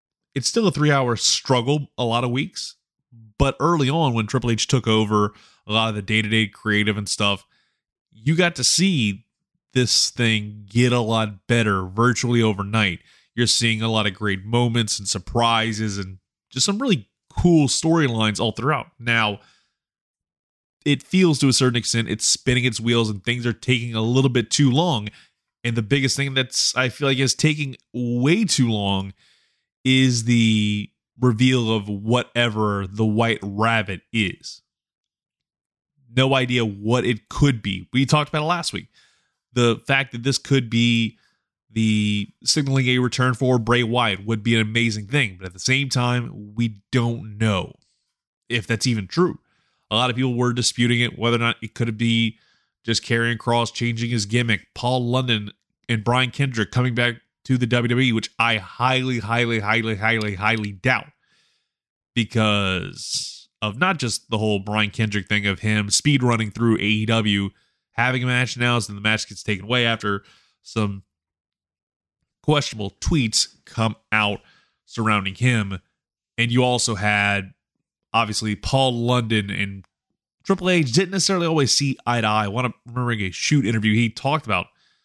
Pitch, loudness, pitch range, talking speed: 115 Hz, -21 LUFS, 110-130 Hz, 165 wpm